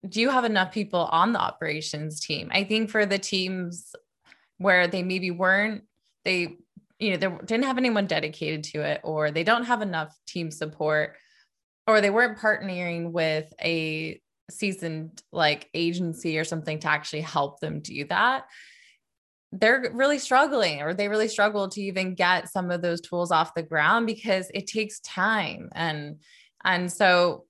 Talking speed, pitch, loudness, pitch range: 165 wpm, 180 Hz, -25 LUFS, 160-210 Hz